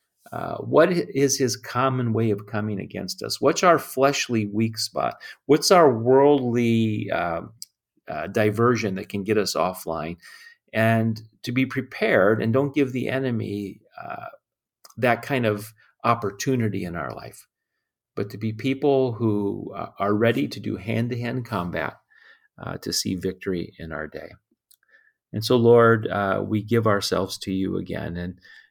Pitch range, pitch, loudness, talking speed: 100-125 Hz, 110 Hz, -23 LUFS, 155 wpm